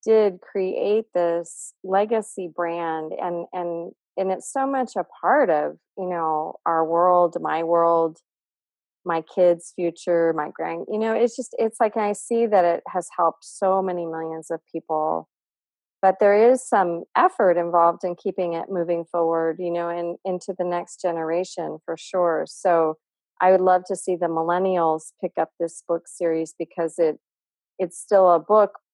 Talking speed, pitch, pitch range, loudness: 170 wpm, 175 Hz, 165-190 Hz, -23 LUFS